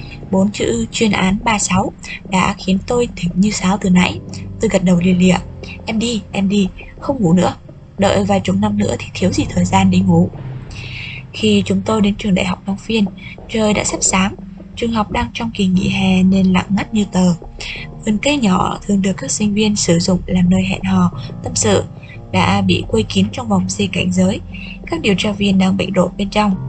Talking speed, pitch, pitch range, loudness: 215 wpm, 190 Hz, 165-200 Hz, -16 LUFS